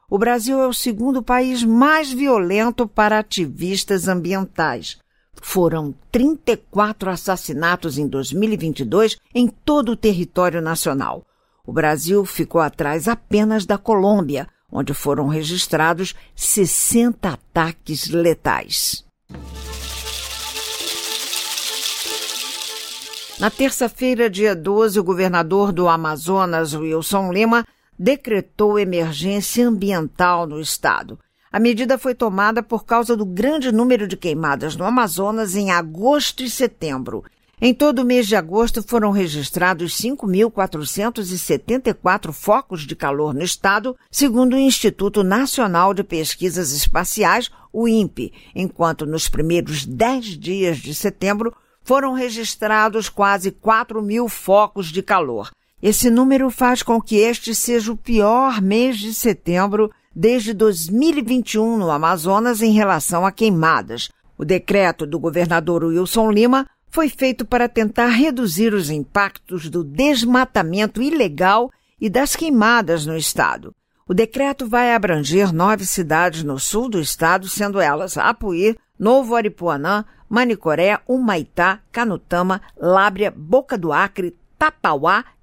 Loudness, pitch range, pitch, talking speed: -18 LUFS, 175-235 Hz, 205 Hz, 115 wpm